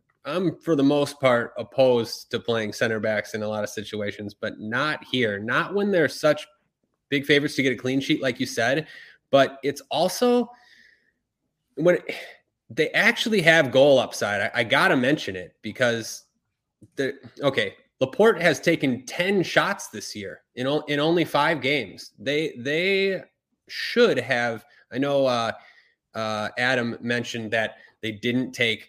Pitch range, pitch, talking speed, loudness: 115-170 Hz, 135 Hz, 160 wpm, -23 LUFS